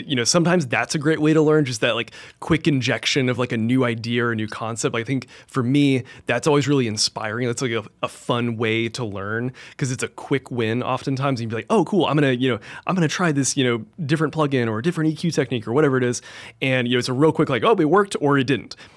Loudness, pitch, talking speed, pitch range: -21 LUFS, 130 Hz, 270 wpm, 120-155 Hz